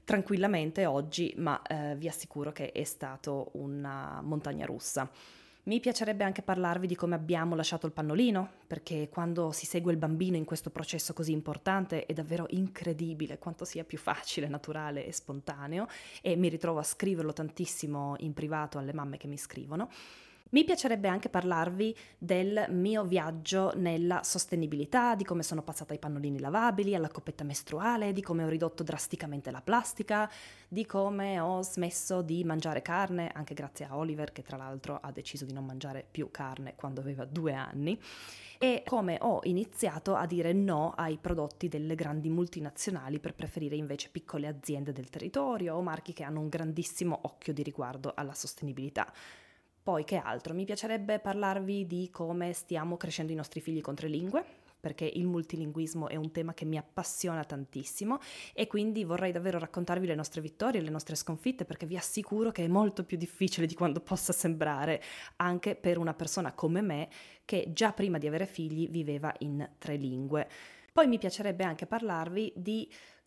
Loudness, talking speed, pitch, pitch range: -34 LUFS, 170 wpm, 165 Hz, 150-185 Hz